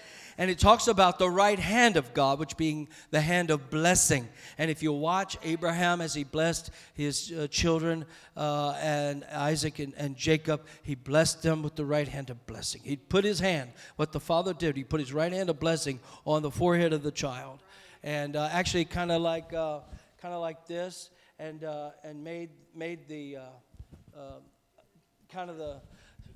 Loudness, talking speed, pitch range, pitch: -29 LUFS, 190 wpm, 145-170 Hz, 155 Hz